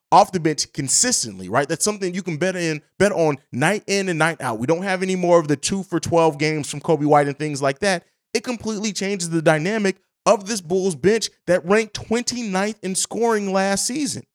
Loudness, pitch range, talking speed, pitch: -20 LUFS, 155-205 Hz, 215 wpm, 185 Hz